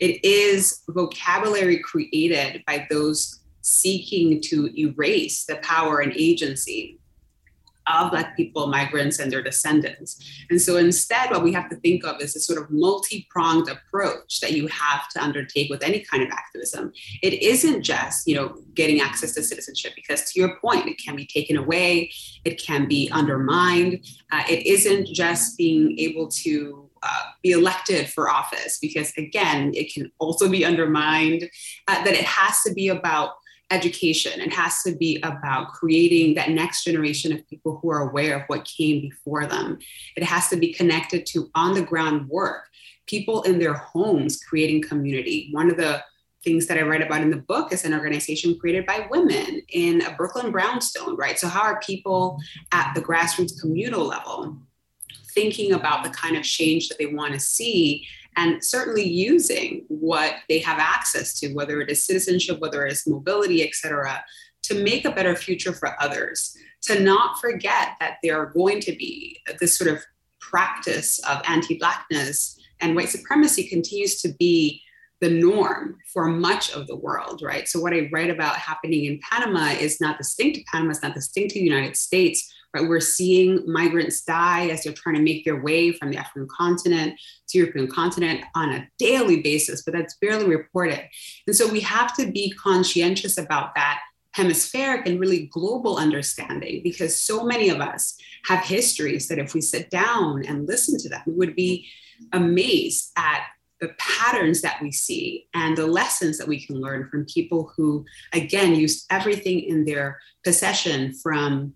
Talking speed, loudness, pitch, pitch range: 175 wpm, -22 LUFS, 170 Hz, 155-195 Hz